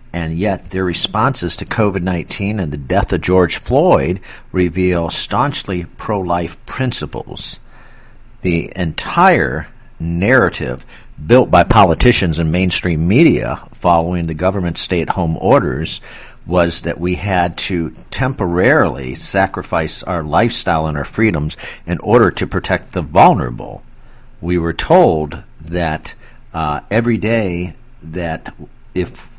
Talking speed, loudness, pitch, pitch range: 125 wpm, -15 LUFS, 90 Hz, 85-95 Hz